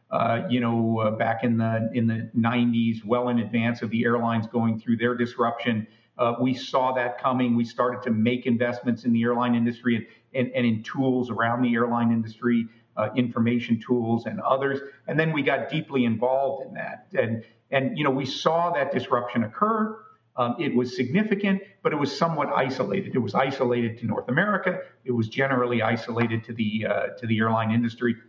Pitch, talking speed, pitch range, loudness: 120 Hz, 195 wpm, 115-130 Hz, -25 LUFS